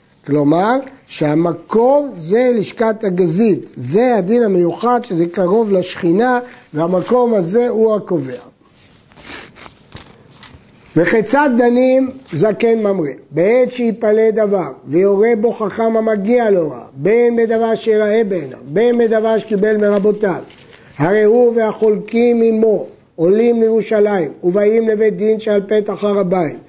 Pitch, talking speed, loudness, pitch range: 215 Hz, 110 wpm, -14 LUFS, 185-230 Hz